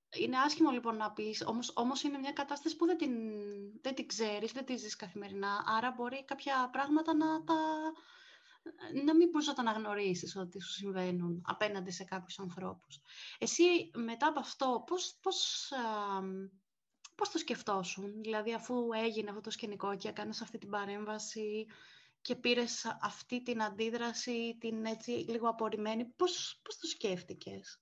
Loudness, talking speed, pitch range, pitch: -36 LUFS, 155 wpm, 210-280 Hz, 230 Hz